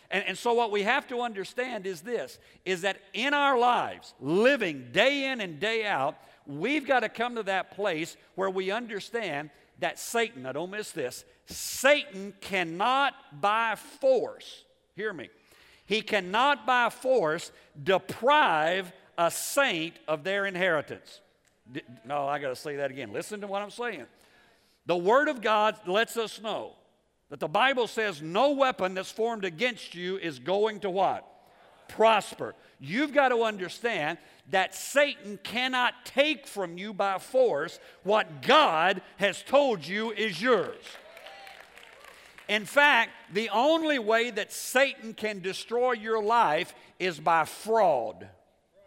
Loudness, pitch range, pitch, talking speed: -27 LUFS, 190-250 Hz, 215 Hz, 145 wpm